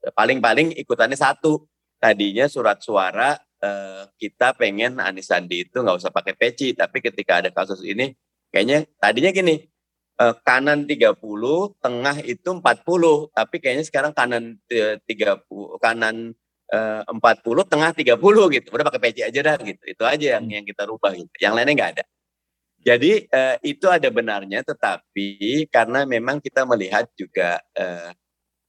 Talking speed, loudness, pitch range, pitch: 145 wpm, -20 LUFS, 100-150 Hz, 115 Hz